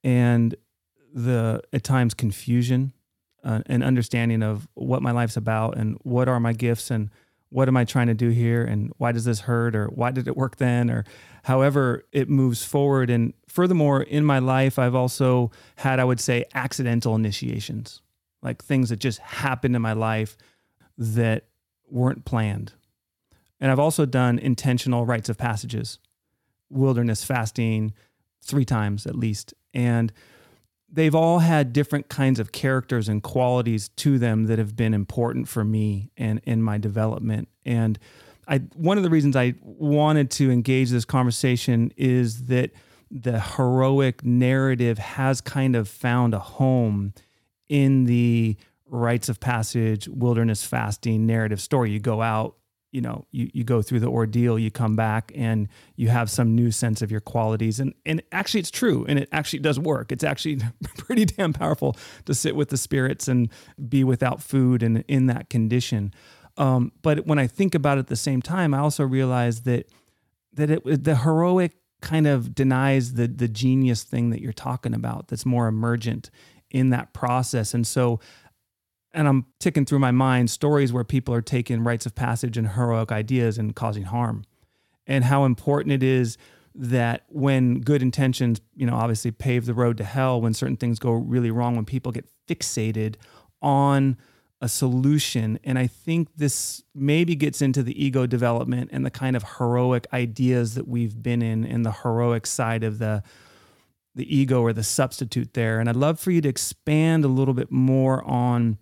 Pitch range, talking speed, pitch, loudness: 115-135 Hz, 175 wpm, 125 Hz, -23 LUFS